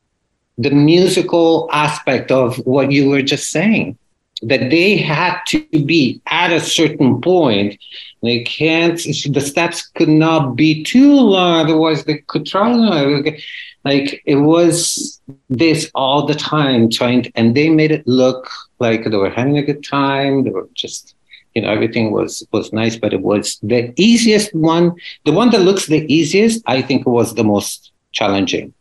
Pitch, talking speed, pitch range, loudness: 150 Hz, 160 wpm, 130-170 Hz, -14 LUFS